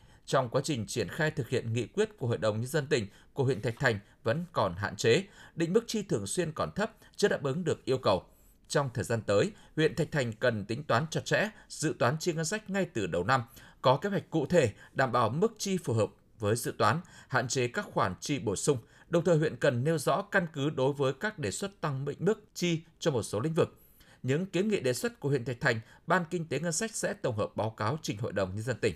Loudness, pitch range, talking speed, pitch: -31 LUFS, 120-175 Hz, 260 wpm, 145 Hz